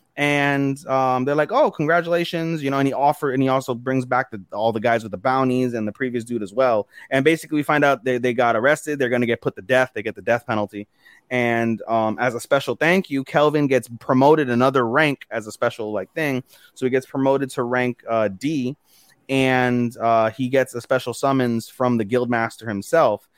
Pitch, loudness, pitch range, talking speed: 130 Hz, -21 LUFS, 120-140 Hz, 220 wpm